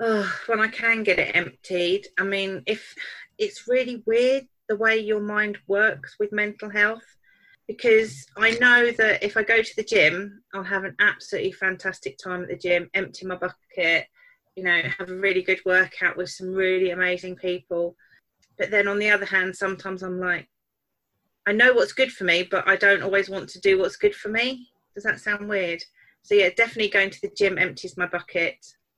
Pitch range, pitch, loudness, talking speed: 185-225 Hz, 200 Hz, -22 LUFS, 195 wpm